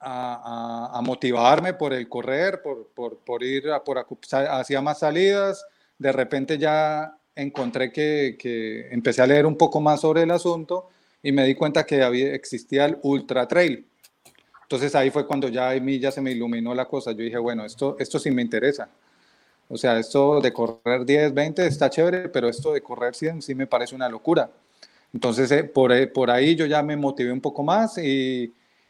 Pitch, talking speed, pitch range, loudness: 135 Hz, 195 wpm, 125-150 Hz, -23 LUFS